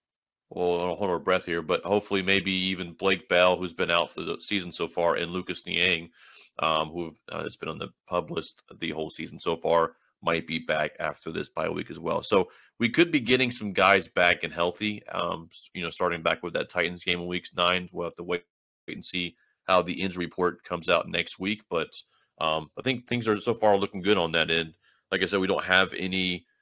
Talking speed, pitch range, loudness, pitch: 230 wpm, 85-100 Hz, -27 LUFS, 90 Hz